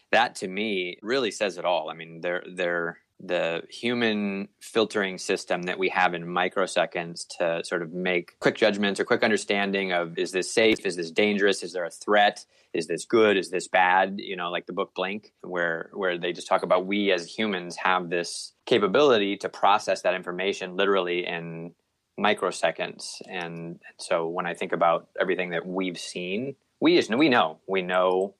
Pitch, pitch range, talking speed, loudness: 90 Hz, 85-100 Hz, 185 wpm, -25 LUFS